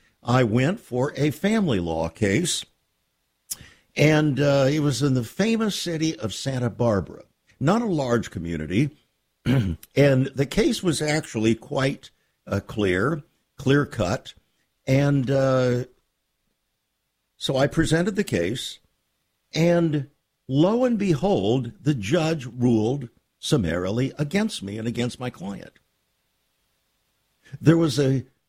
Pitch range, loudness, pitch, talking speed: 120-155 Hz, -23 LUFS, 135 Hz, 120 wpm